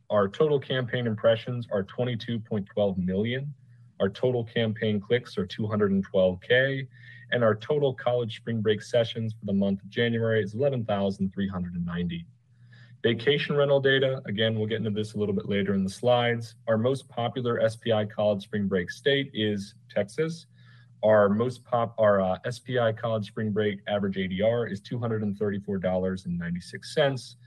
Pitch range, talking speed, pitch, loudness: 100-120 Hz, 140 wpm, 110 Hz, -27 LUFS